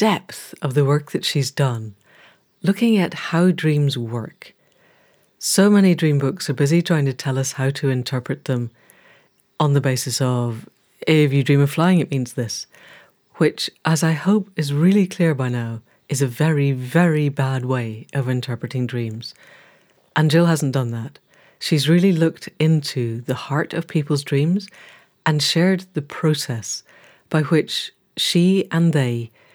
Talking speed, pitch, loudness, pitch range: 160 wpm, 145 Hz, -20 LUFS, 130-165 Hz